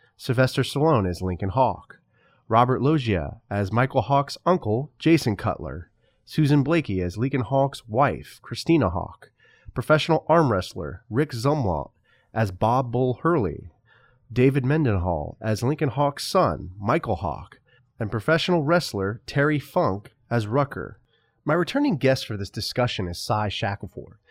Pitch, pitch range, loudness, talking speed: 125 Hz, 100-145 Hz, -24 LUFS, 135 wpm